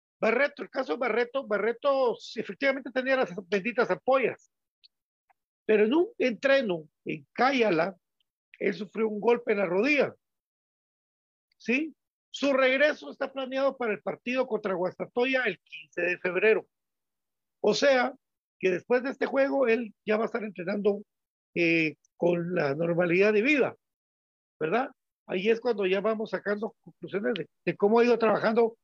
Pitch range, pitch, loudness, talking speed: 190-260 Hz, 220 Hz, -27 LUFS, 150 wpm